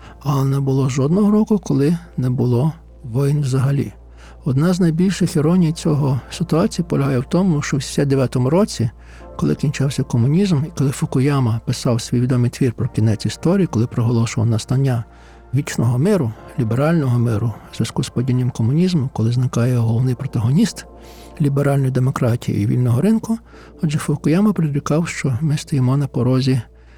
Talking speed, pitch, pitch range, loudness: 145 wpm, 135 Hz, 120-155 Hz, -18 LUFS